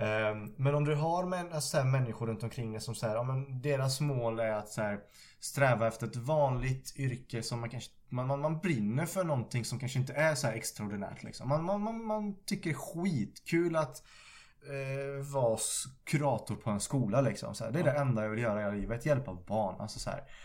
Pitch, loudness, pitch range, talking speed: 130 Hz, -34 LUFS, 115-150 Hz, 210 wpm